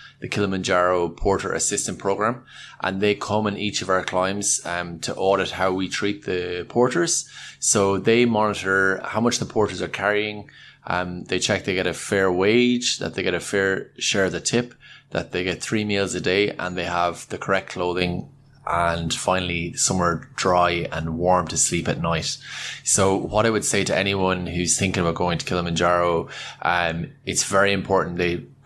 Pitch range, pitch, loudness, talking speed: 90-105 Hz, 95 Hz, -22 LUFS, 185 wpm